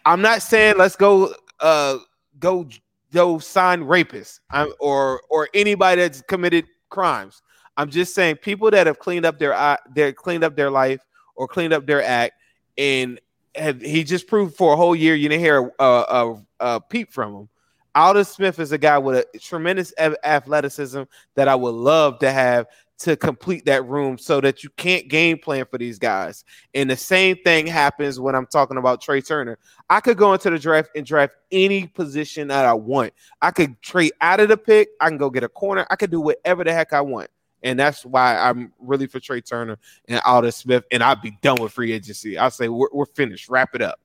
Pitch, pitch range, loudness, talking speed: 145 Hz, 130-175 Hz, -19 LUFS, 210 wpm